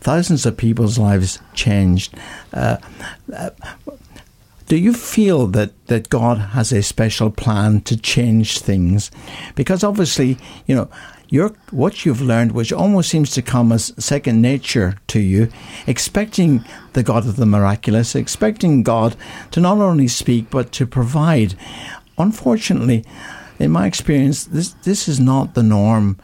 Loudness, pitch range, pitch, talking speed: -16 LUFS, 110-155 Hz, 120 Hz, 140 wpm